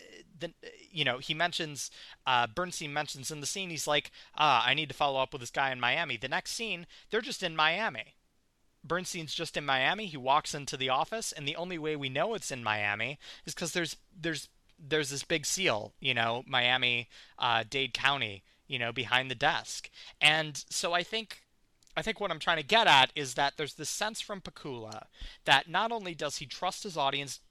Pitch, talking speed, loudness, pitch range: 150 Hz, 205 wpm, -30 LUFS, 135-175 Hz